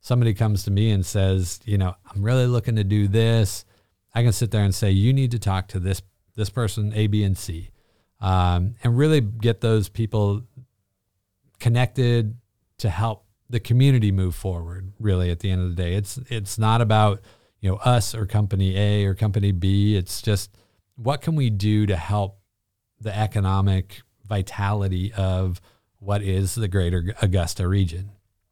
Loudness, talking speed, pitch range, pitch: -23 LUFS, 175 wpm, 95-115 Hz, 105 Hz